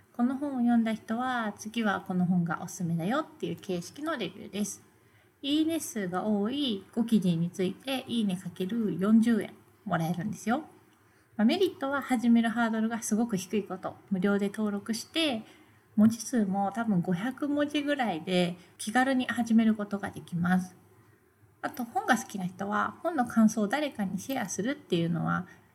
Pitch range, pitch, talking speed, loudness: 190-250 Hz, 220 Hz, 330 characters per minute, -30 LUFS